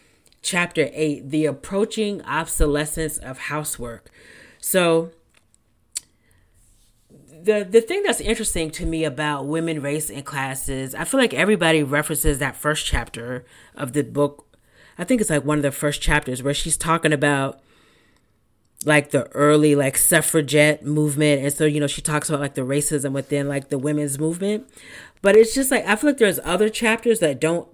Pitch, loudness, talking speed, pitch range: 150 Hz, -20 LUFS, 165 wpm, 140-165 Hz